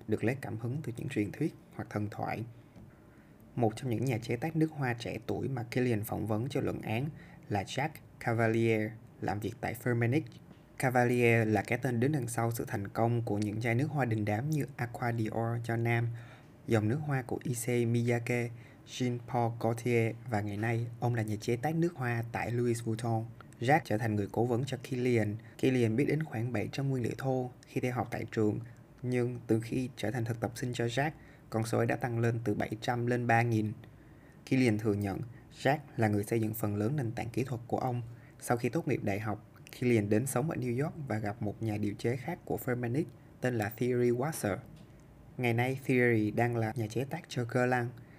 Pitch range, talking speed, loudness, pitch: 110-130 Hz, 215 wpm, -33 LUFS, 120 Hz